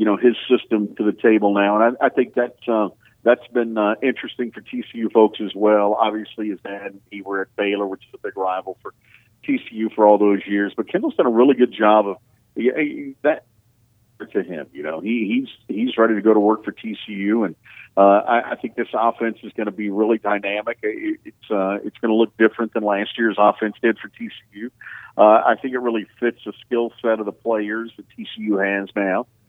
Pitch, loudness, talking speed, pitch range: 110 Hz, -20 LUFS, 225 wpm, 105-120 Hz